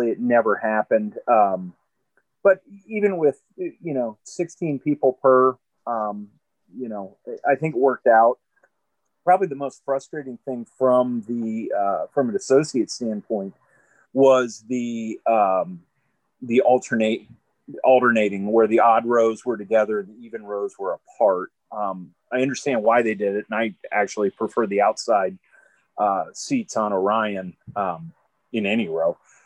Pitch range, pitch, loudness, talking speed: 110-140 Hz, 120 Hz, -22 LUFS, 145 wpm